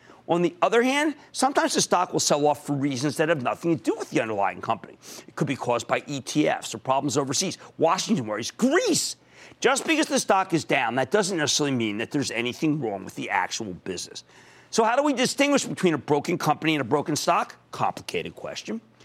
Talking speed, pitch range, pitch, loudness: 210 wpm, 145-210 Hz, 155 Hz, -24 LUFS